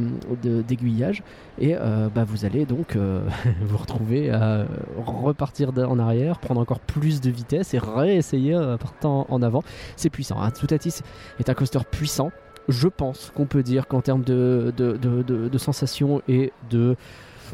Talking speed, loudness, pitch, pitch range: 175 wpm, -23 LUFS, 125 Hz, 115-140 Hz